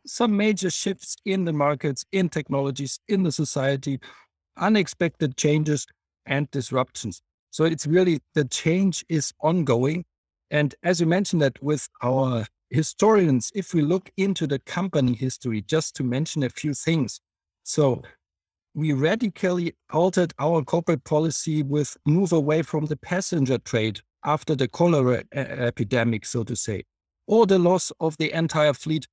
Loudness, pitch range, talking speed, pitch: -24 LUFS, 130-170 Hz, 145 wpm, 150 Hz